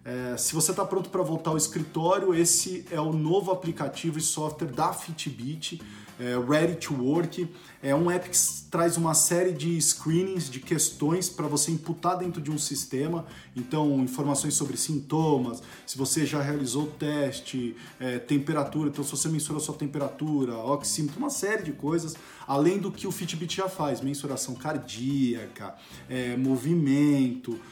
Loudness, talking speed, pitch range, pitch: -27 LUFS, 160 wpm, 135-170 Hz, 150 Hz